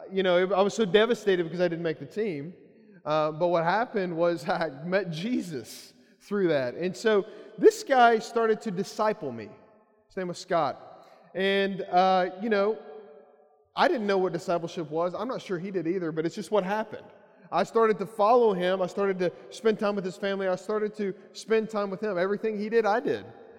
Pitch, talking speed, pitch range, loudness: 195 Hz, 205 wpm, 175-215 Hz, -27 LUFS